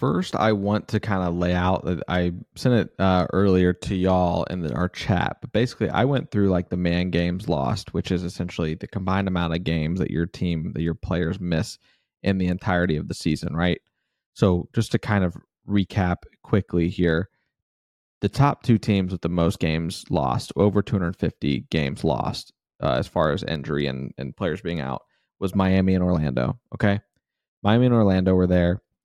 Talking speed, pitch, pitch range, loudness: 190 wpm, 90 Hz, 85-100 Hz, -23 LUFS